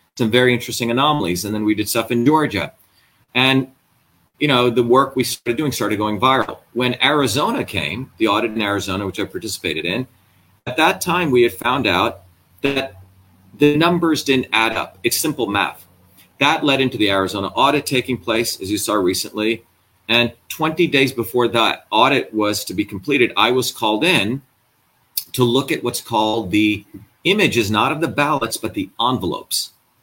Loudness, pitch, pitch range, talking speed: -18 LUFS, 120 Hz, 105-135 Hz, 180 wpm